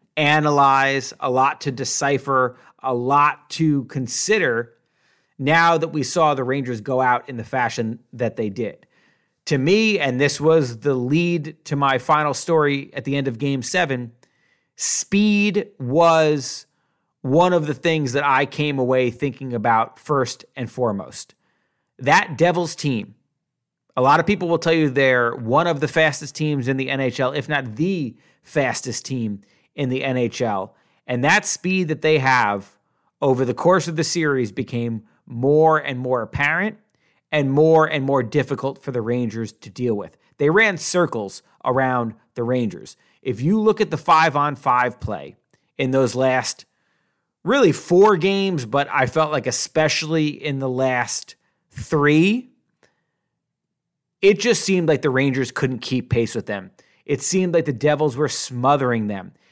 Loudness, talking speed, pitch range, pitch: -20 LUFS, 160 wpm, 125-160 Hz, 140 Hz